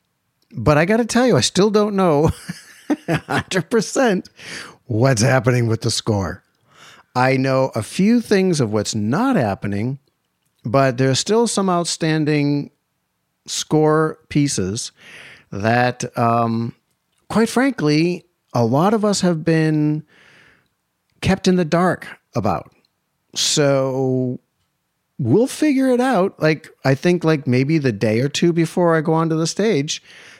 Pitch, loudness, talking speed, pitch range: 150 Hz, -18 LUFS, 130 wpm, 125-180 Hz